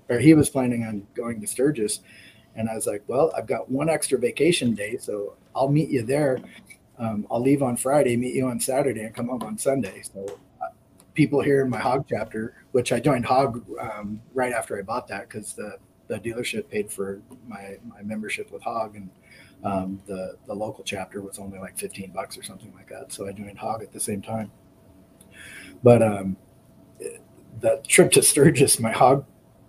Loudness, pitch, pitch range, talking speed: -24 LUFS, 120 Hz, 100-140 Hz, 200 wpm